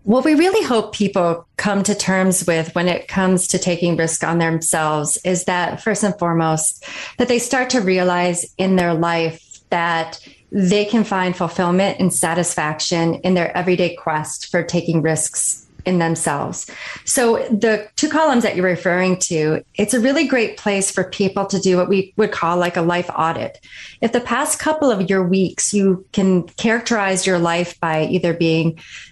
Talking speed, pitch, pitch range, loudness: 175 wpm, 185 Hz, 170-205 Hz, -18 LUFS